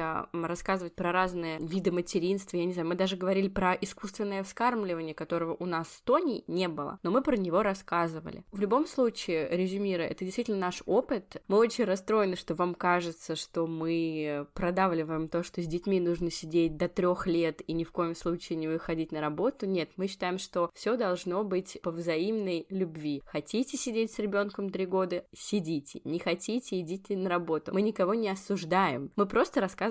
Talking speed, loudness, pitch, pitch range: 180 wpm, -31 LUFS, 180 Hz, 170-200 Hz